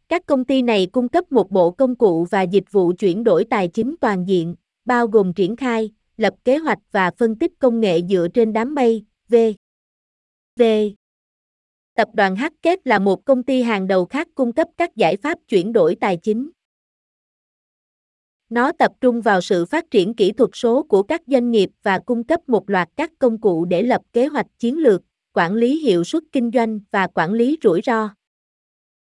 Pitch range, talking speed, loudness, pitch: 200-270 Hz, 195 wpm, -18 LUFS, 230 Hz